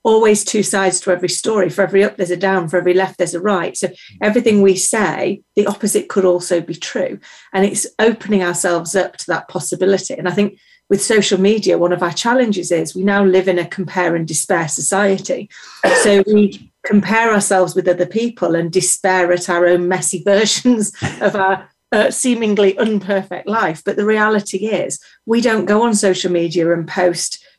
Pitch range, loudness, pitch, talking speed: 180-210 Hz, -15 LUFS, 190 Hz, 190 wpm